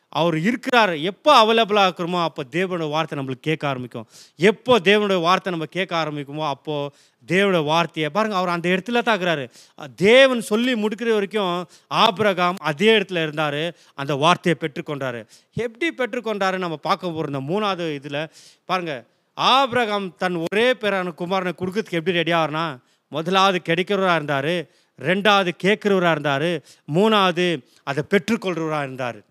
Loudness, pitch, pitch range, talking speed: -20 LUFS, 175 Hz, 155-205 Hz, 130 wpm